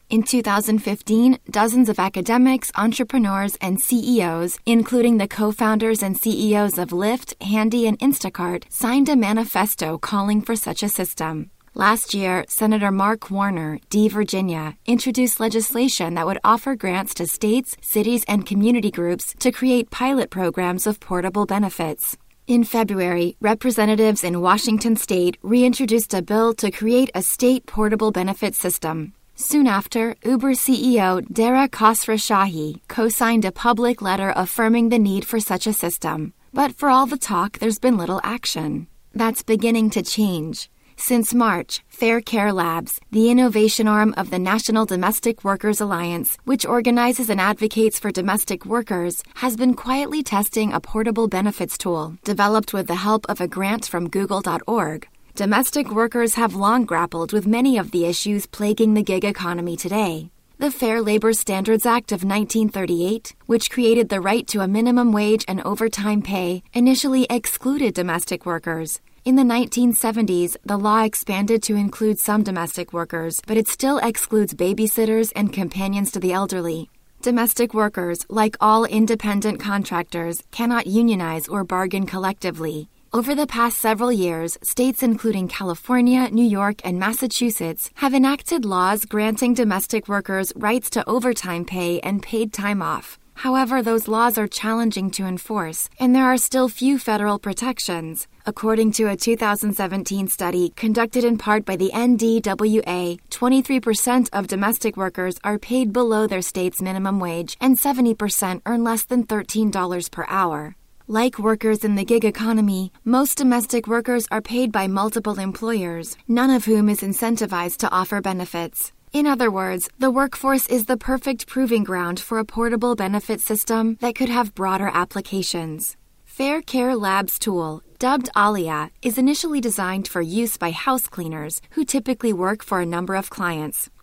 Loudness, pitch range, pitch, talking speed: -20 LUFS, 190-235 Hz, 215 Hz, 155 wpm